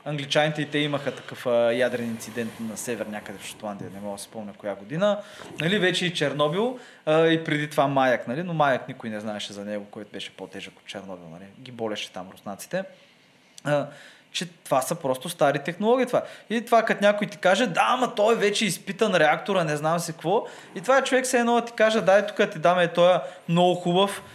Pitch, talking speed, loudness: 165 Hz, 215 wpm, -24 LUFS